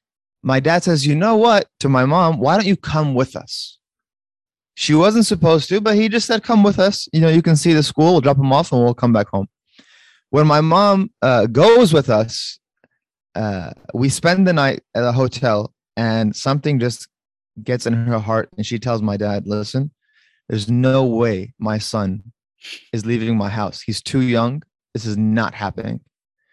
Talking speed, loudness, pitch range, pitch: 195 wpm, -17 LUFS, 115-165 Hz, 130 Hz